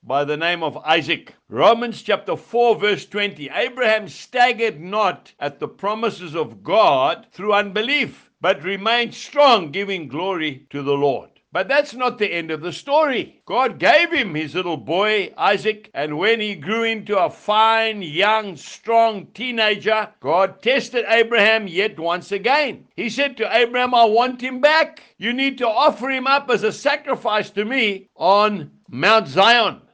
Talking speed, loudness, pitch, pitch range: 160 wpm, -19 LUFS, 215 Hz, 190-240 Hz